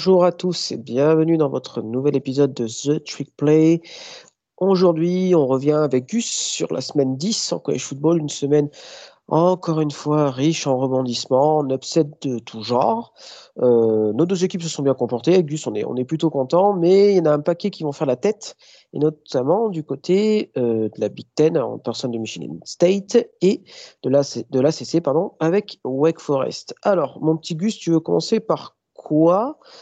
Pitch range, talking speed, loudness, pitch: 130-180 Hz, 195 wpm, -20 LUFS, 155 Hz